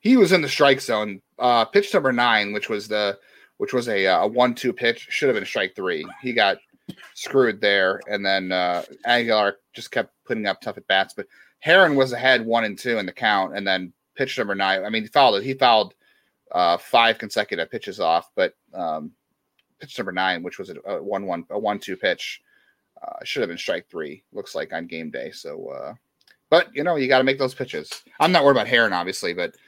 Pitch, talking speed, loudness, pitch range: 120 Hz, 225 wpm, -21 LUFS, 105-145 Hz